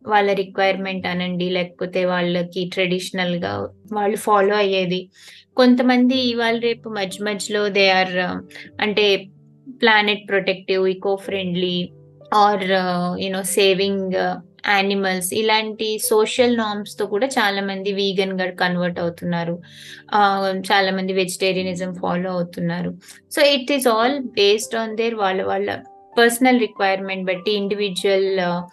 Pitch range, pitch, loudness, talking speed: 185-210 Hz, 195 Hz, -19 LUFS, 110 wpm